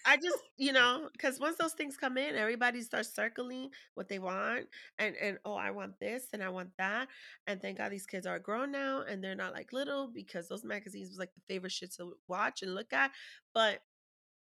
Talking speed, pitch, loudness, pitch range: 220 wpm, 220 Hz, -36 LUFS, 190-270 Hz